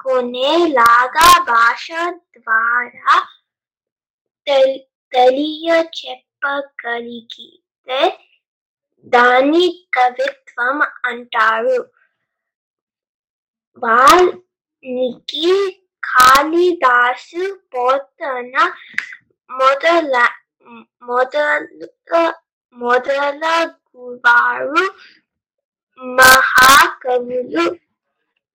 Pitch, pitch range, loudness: 270 Hz, 250-335 Hz, -14 LUFS